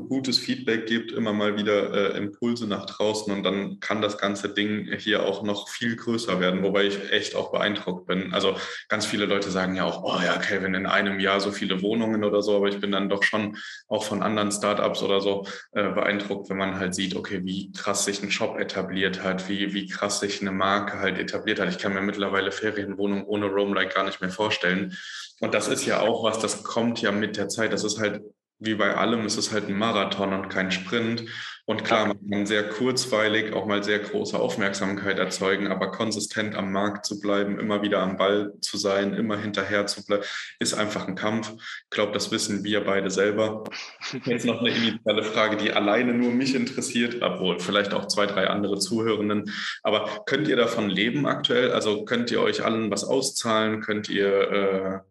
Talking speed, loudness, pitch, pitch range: 205 wpm, -25 LUFS, 100 Hz, 100-105 Hz